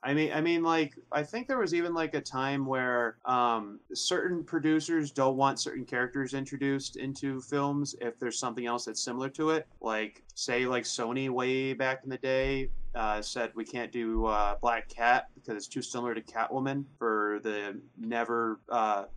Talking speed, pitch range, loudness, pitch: 185 wpm, 115-140 Hz, -31 LUFS, 130 Hz